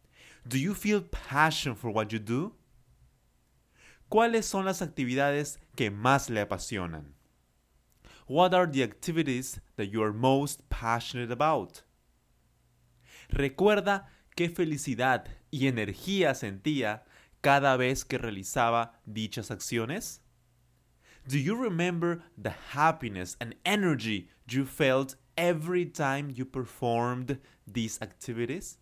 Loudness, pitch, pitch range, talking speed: -30 LUFS, 130 Hz, 105-150 Hz, 110 wpm